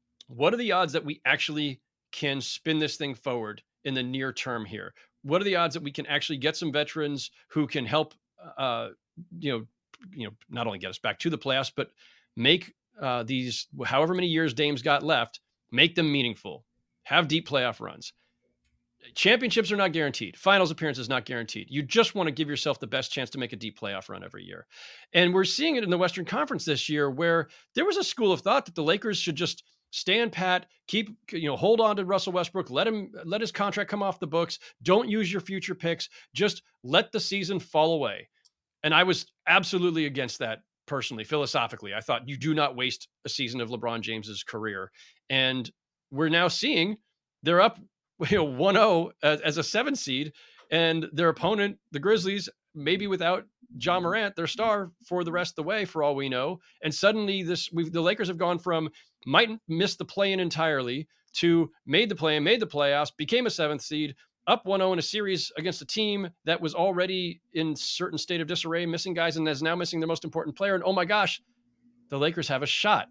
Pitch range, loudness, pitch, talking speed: 145-190 Hz, -27 LUFS, 165 Hz, 210 wpm